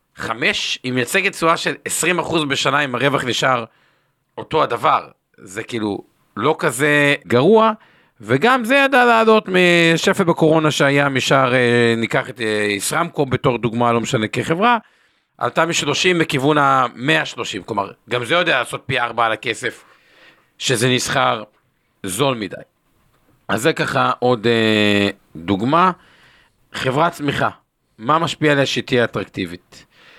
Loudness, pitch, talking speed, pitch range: -17 LUFS, 140 Hz, 125 wpm, 120-165 Hz